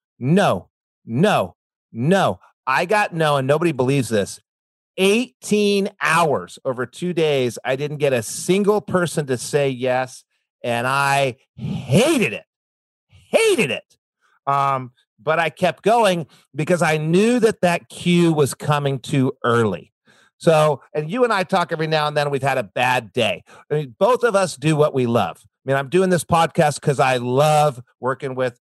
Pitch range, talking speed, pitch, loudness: 130-175 Hz, 170 wpm, 150 Hz, -19 LUFS